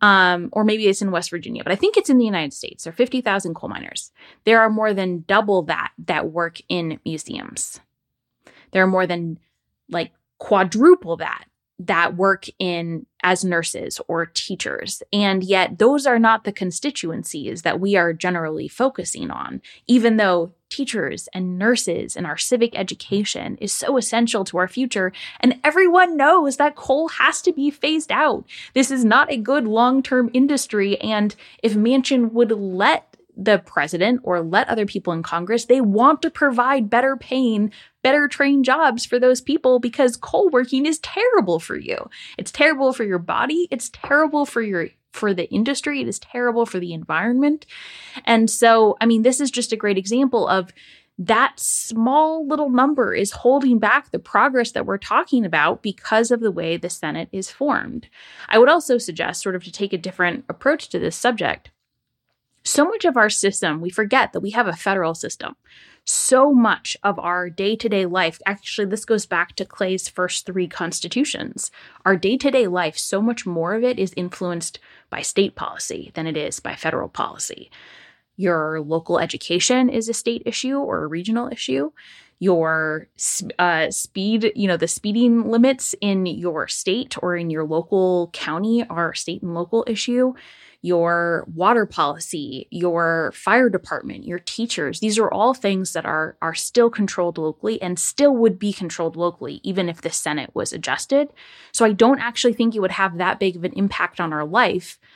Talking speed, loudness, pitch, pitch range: 180 wpm, -20 LUFS, 210 Hz, 180-250 Hz